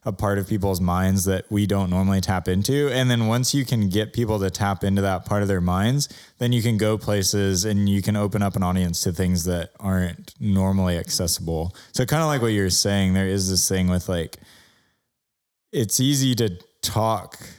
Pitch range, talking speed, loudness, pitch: 95-110 Hz, 210 wpm, -22 LUFS, 100 Hz